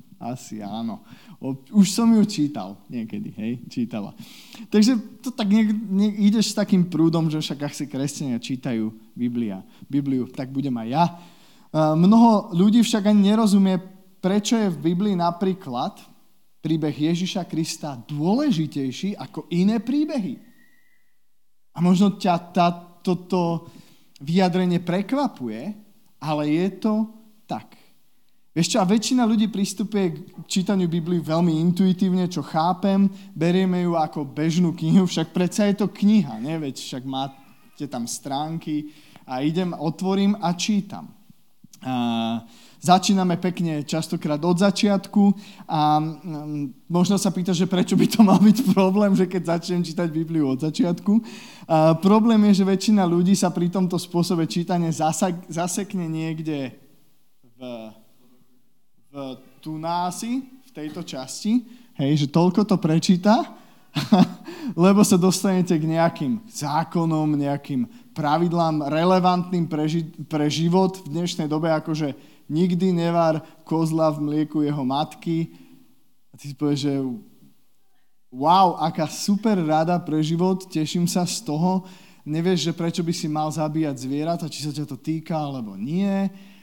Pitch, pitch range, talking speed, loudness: 175 Hz, 155-200 Hz, 135 wpm, -22 LUFS